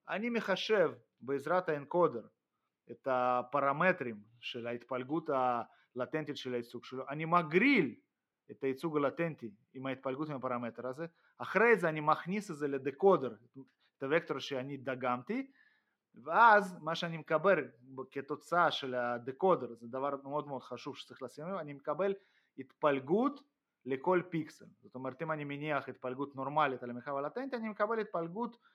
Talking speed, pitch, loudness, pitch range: 135 wpm, 145 Hz, -34 LUFS, 130-175 Hz